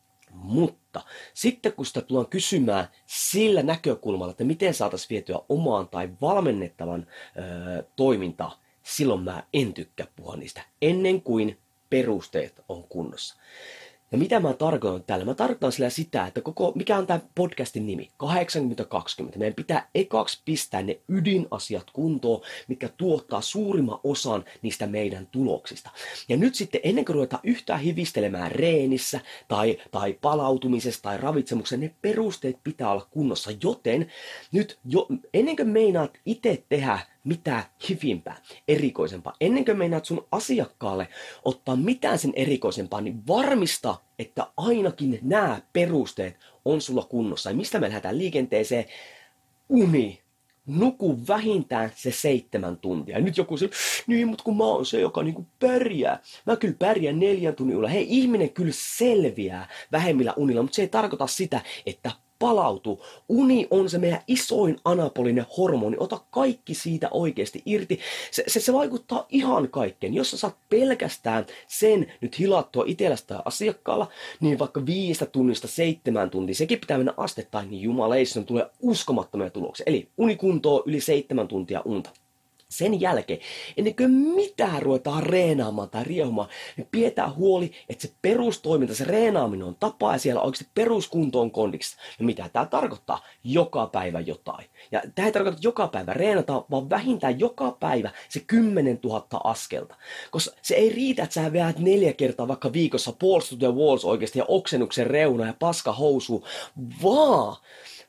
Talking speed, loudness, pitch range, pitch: 145 wpm, -25 LUFS, 125-205 Hz, 155 Hz